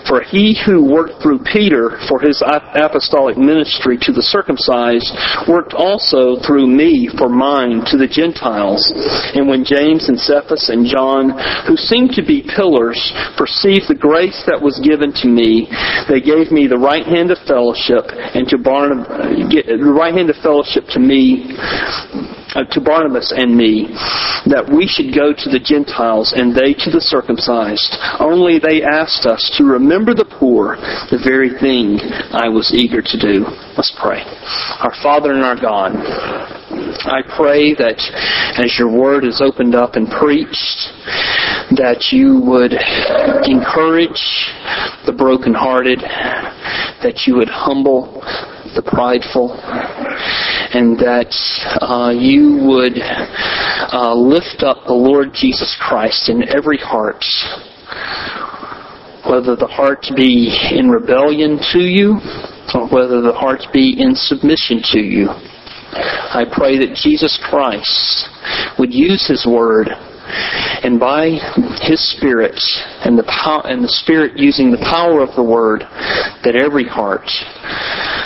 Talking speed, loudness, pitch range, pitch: 140 wpm, -13 LUFS, 125-175 Hz, 145 Hz